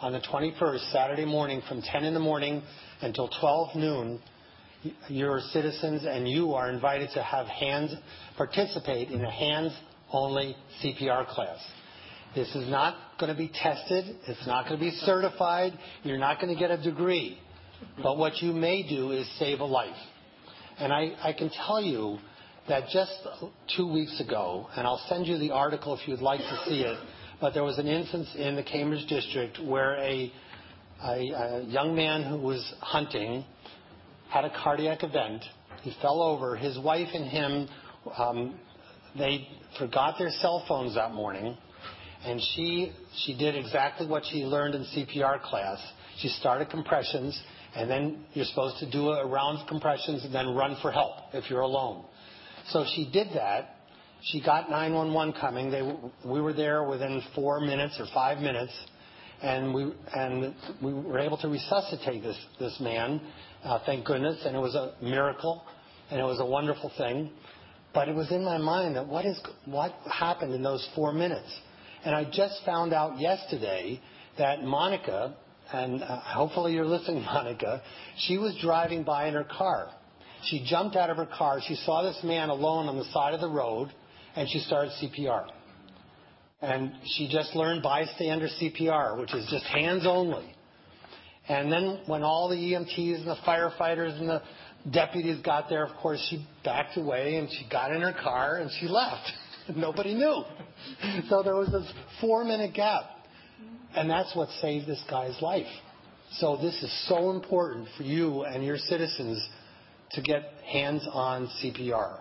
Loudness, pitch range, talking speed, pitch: -30 LUFS, 130-165 Hz, 170 wpm, 150 Hz